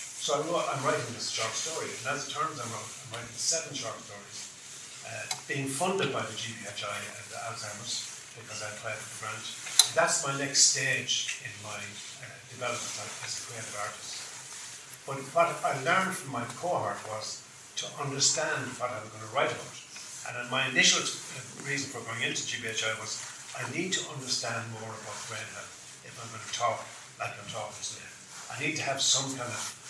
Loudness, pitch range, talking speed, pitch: -30 LUFS, 110-145 Hz, 190 wpm, 130 Hz